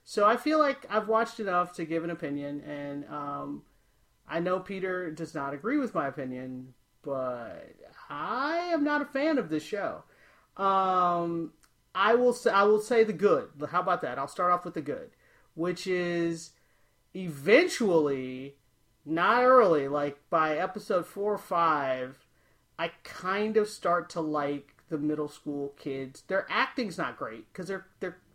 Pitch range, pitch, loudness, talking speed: 145-200 Hz, 170 Hz, -29 LUFS, 165 wpm